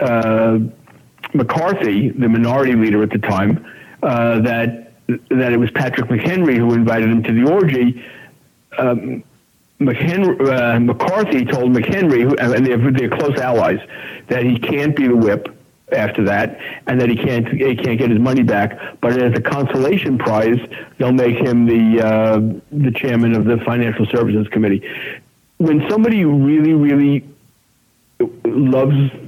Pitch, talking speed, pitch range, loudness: 120 Hz, 145 wpm, 115-135 Hz, -16 LUFS